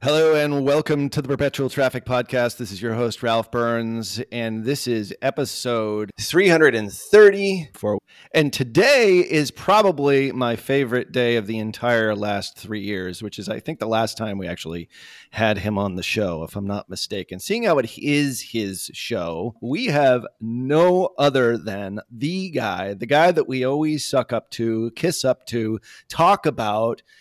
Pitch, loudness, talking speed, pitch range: 120 Hz, -21 LUFS, 170 wpm, 110-140 Hz